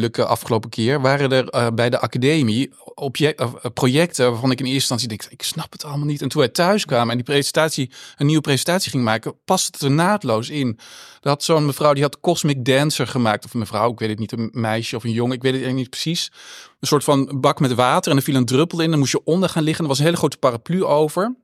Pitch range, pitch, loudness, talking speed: 125-155 Hz, 140 Hz, -19 LUFS, 245 wpm